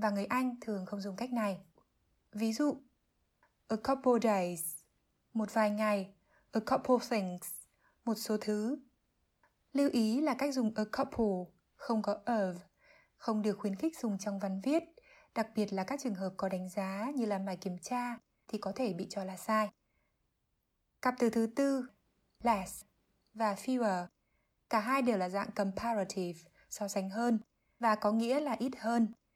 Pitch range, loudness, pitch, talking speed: 200-250 Hz, -35 LUFS, 220 Hz, 170 wpm